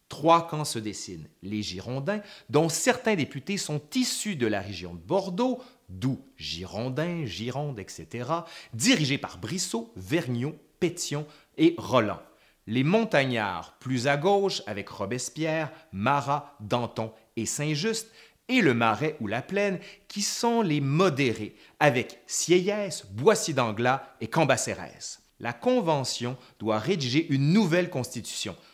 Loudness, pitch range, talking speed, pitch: -27 LUFS, 115-180 Hz, 125 wpm, 145 Hz